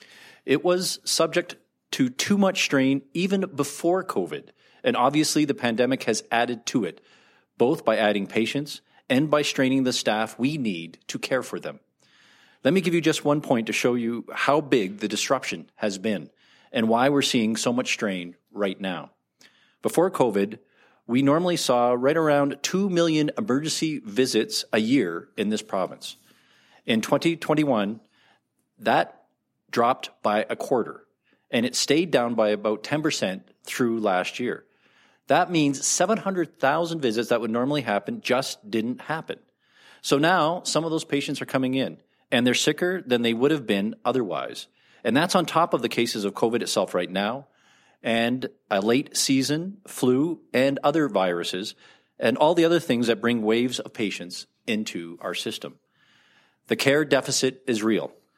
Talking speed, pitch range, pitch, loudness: 160 wpm, 115-160 Hz, 135 Hz, -24 LUFS